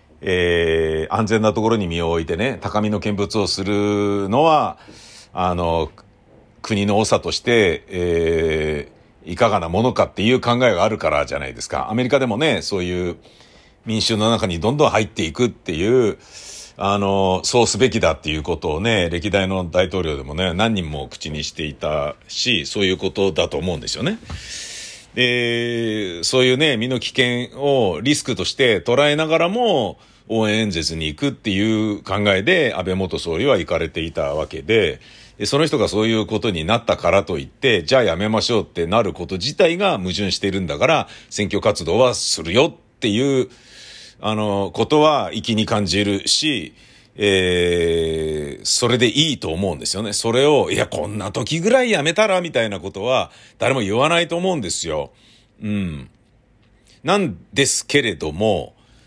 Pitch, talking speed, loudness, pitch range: 105 Hz, 325 characters per minute, -19 LUFS, 90-120 Hz